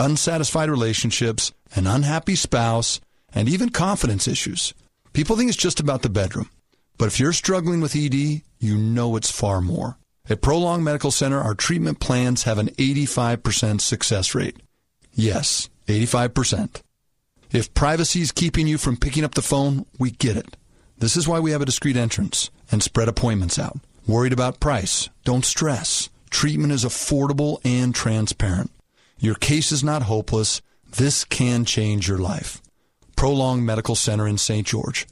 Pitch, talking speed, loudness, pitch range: 125 Hz, 155 wpm, -21 LUFS, 110-145 Hz